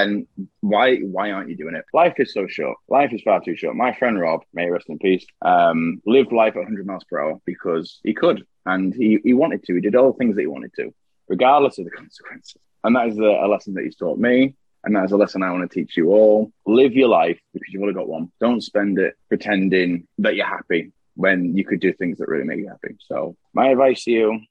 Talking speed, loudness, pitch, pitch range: 255 wpm, -19 LUFS, 100 Hz, 95-110 Hz